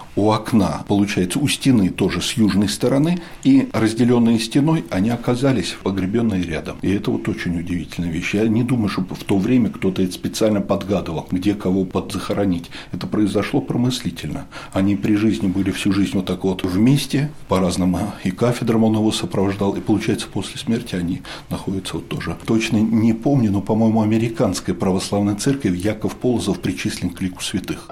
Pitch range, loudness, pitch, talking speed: 95-115 Hz, -20 LUFS, 100 Hz, 165 wpm